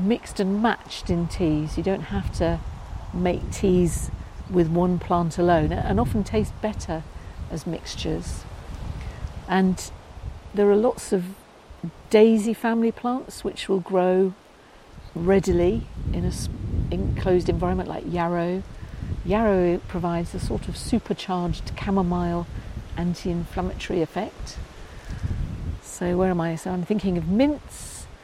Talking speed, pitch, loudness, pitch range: 125 wpm, 180 Hz, -24 LUFS, 170-195 Hz